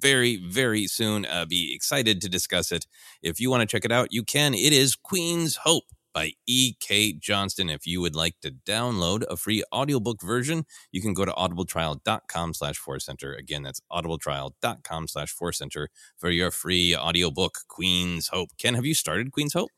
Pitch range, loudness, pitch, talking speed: 85-125 Hz, -25 LUFS, 95 Hz, 175 wpm